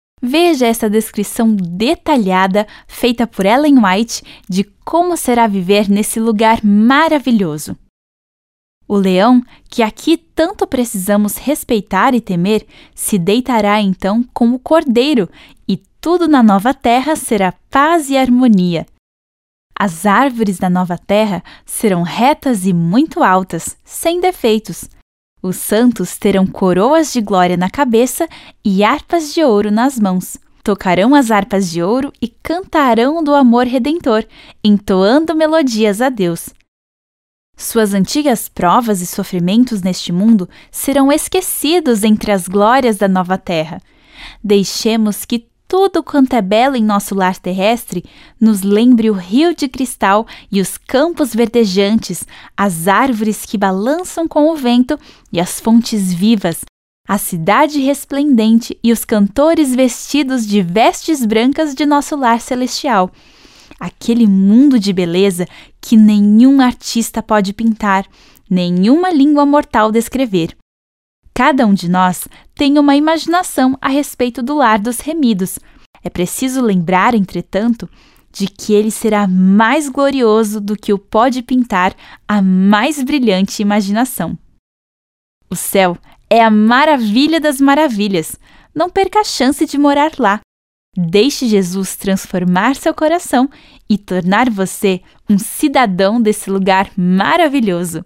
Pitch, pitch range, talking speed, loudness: 225 Hz, 195-275 Hz, 130 wpm, -13 LUFS